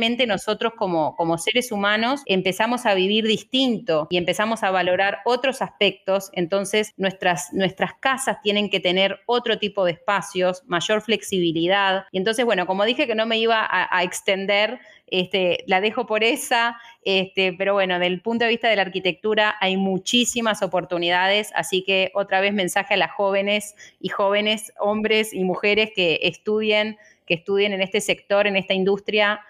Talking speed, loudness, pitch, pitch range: 165 wpm, -21 LUFS, 200 Hz, 185-215 Hz